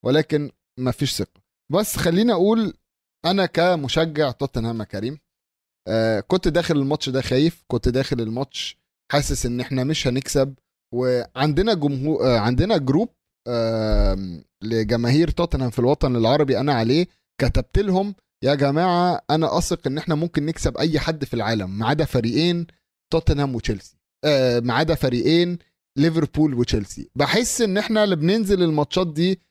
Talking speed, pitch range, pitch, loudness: 130 wpm, 120-170 Hz, 140 Hz, -21 LUFS